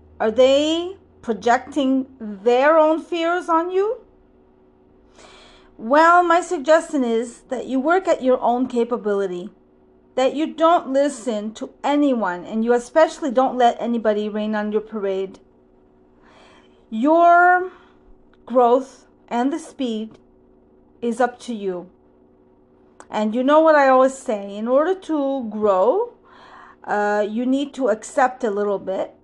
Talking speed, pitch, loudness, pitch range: 130 wpm, 255 Hz, -19 LUFS, 215-310 Hz